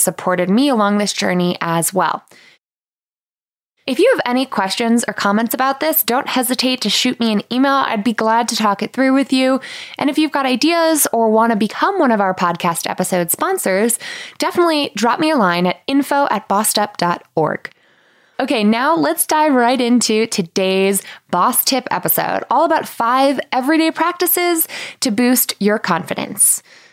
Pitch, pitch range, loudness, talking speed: 245 Hz, 205-290 Hz, -16 LUFS, 165 wpm